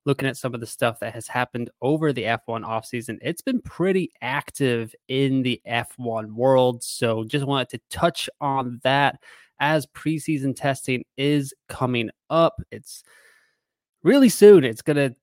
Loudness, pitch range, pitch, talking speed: -22 LUFS, 120-155 Hz, 135 Hz, 160 wpm